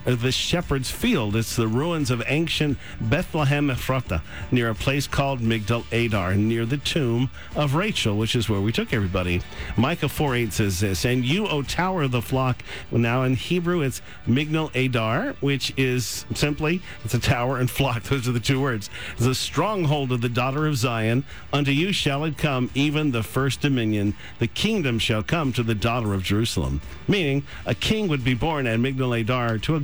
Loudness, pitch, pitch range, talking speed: -23 LUFS, 130 Hz, 115-145 Hz, 185 wpm